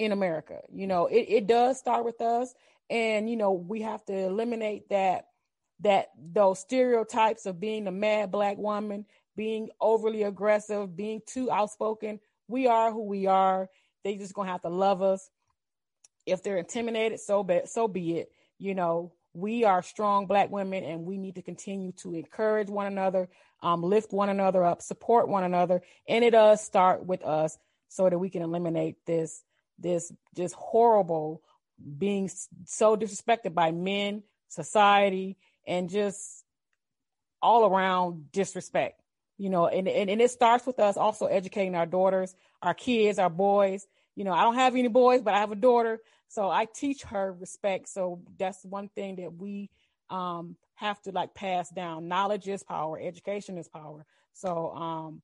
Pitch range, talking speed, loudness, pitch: 180-215 Hz, 170 wpm, -27 LUFS, 195 Hz